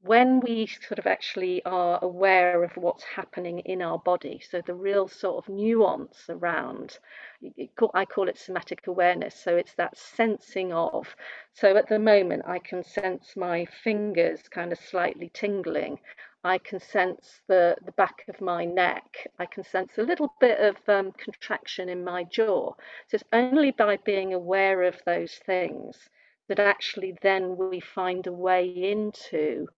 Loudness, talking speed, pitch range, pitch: -26 LUFS, 165 wpm, 180-205 Hz, 185 Hz